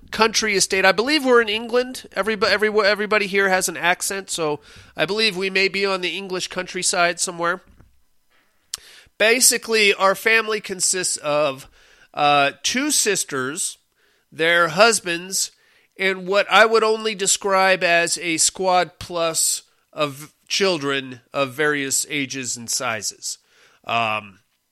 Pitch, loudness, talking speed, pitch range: 185 Hz, -19 LUFS, 130 wpm, 155-210 Hz